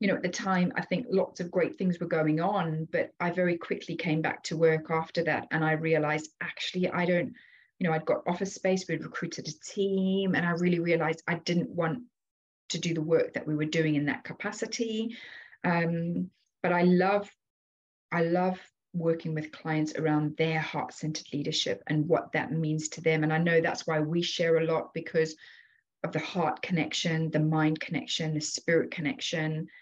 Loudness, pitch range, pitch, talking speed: -29 LUFS, 155-180 Hz, 165 Hz, 195 wpm